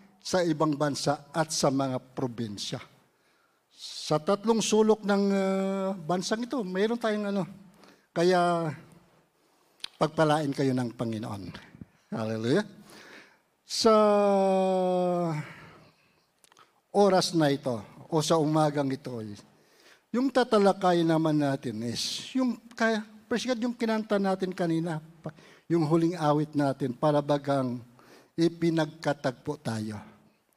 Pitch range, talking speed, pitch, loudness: 145-195 Hz, 100 wpm, 165 Hz, -27 LUFS